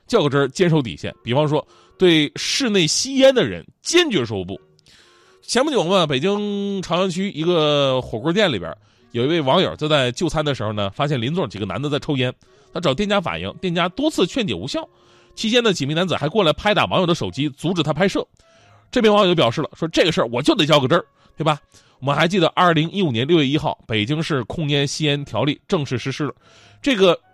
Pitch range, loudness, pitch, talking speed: 140-190 Hz, -19 LUFS, 155 Hz, 340 characters per minute